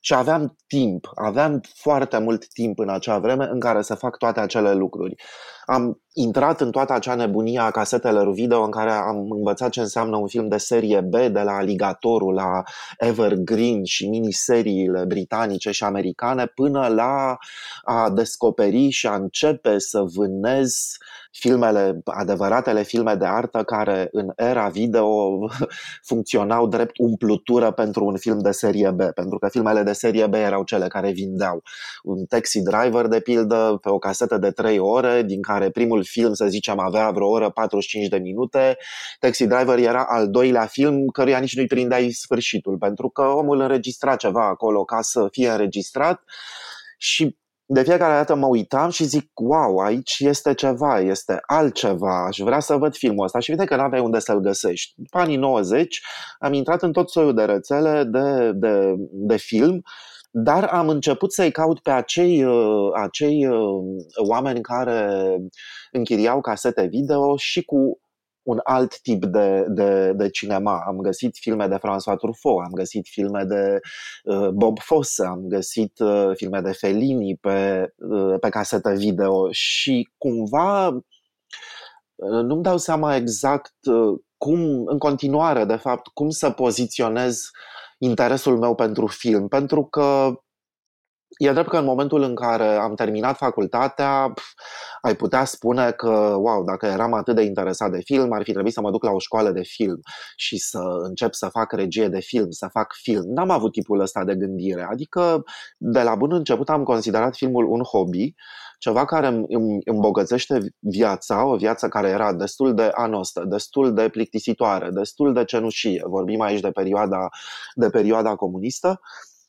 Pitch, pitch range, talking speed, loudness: 115 Hz, 100-135 Hz, 160 wpm, -21 LUFS